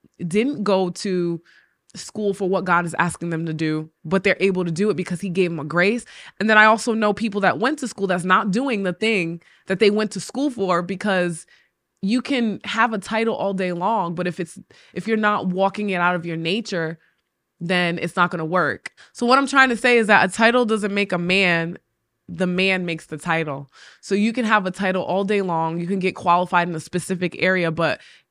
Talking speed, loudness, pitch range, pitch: 230 wpm, -20 LUFS, 175-210 Hz, 185 Hz